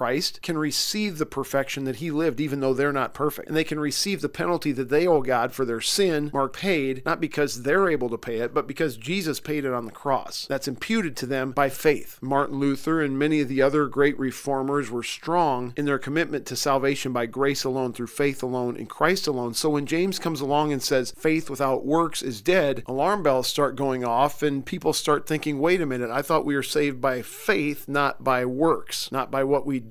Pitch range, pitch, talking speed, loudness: 130-155 Hz, 140 Hz, 225 wpm, -25 LUFS